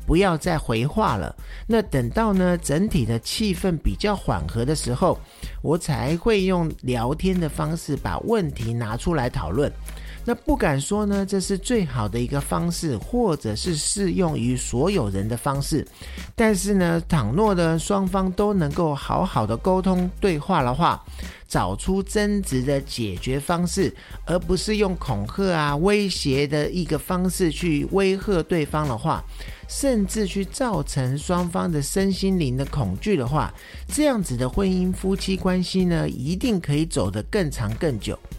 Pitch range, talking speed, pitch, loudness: 135-195 Hz, 240 characters per minute, 170 Hz, -23 LUFS